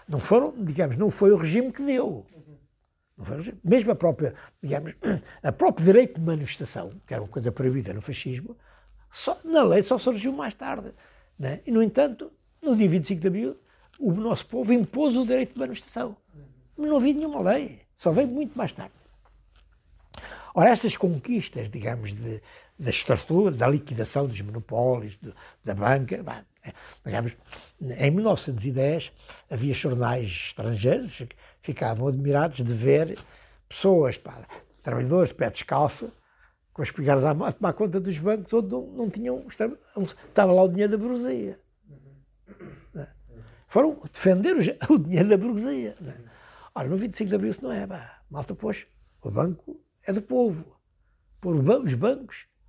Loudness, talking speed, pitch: -25 LUFS, 155 wpm, 175 Hz